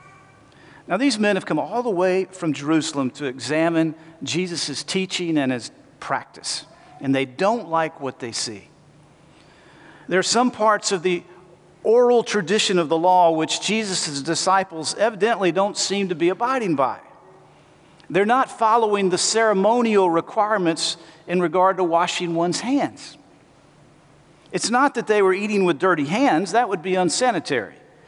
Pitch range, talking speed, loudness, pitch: 165-215 Hz, 150 wpm, -21 LUFS, 185 Hz